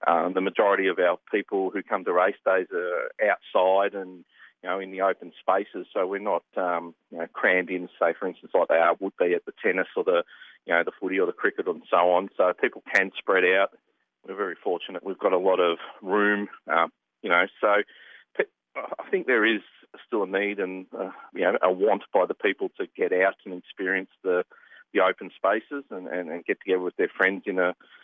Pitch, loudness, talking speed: 140 Hz, -25 LUFS, 225 wpm